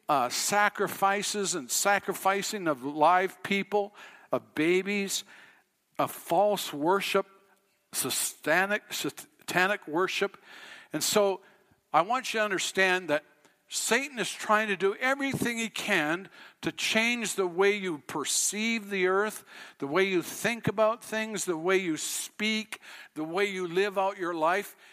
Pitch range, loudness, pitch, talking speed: 190-215 Hz, -28 LUFS, 200 Hz, 135 wpm